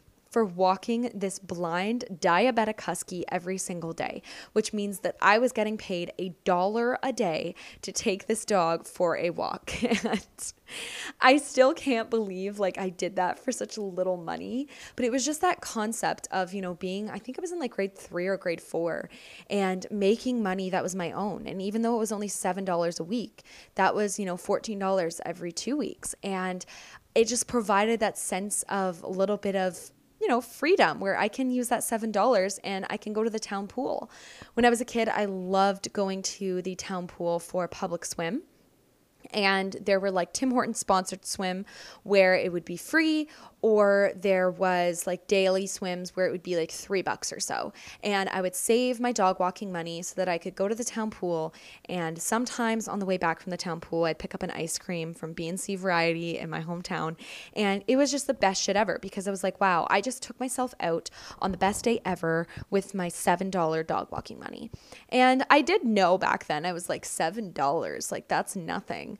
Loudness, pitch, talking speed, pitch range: -28 LUFS, 195 Hz, 210 wpm, 180-225 Hz